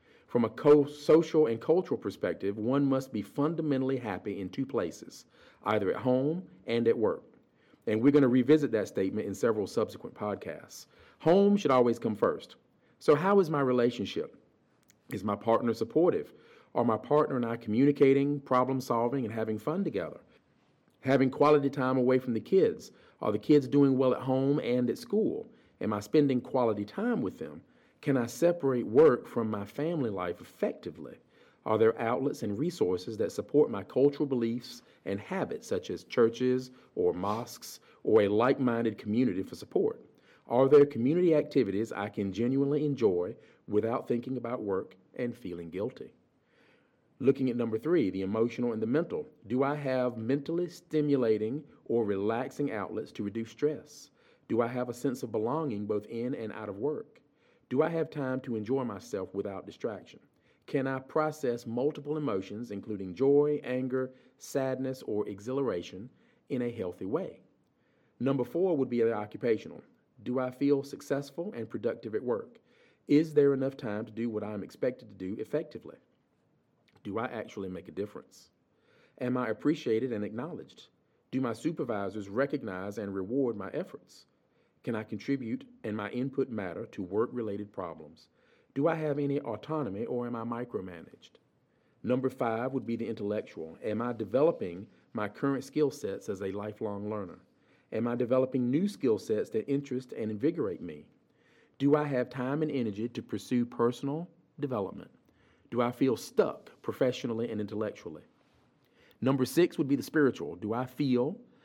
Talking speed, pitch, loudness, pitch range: 165 wpm, 130 Hz, -31 LUFS, 115-145 Hz